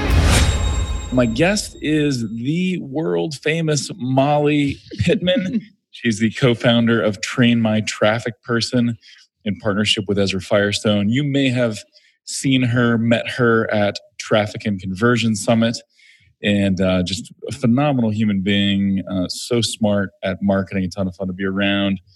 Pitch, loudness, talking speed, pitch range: 115 Hz, -19 LUFS, 145 wpm, 100-125 Hz